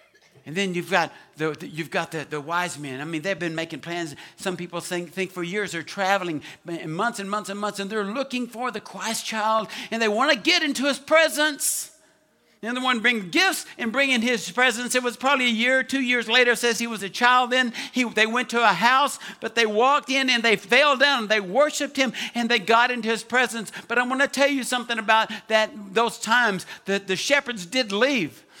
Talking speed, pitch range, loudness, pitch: 230 wpm, 195-255 Hz, -22 LUFS, 230 Hz